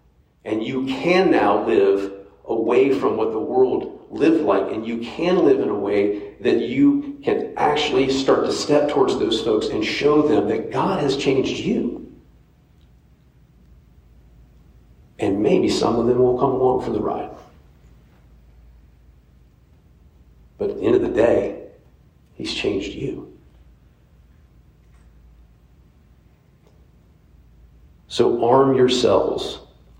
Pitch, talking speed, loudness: 80 Hz, 120 wpm, -20 LUFS